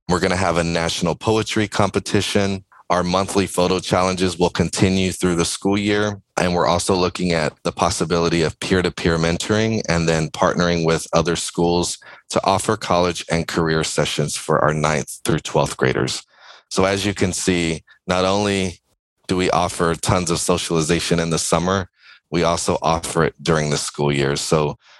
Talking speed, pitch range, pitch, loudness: 175 wpm, 85-95 Hz, 90 Hz, -19 LUFS